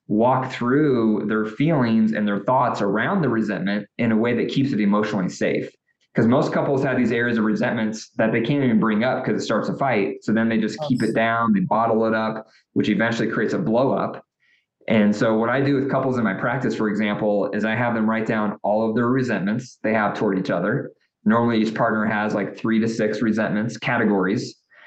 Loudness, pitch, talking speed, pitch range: -21 LUFS, 110 Hz, 220 wpm, 110-120 Hz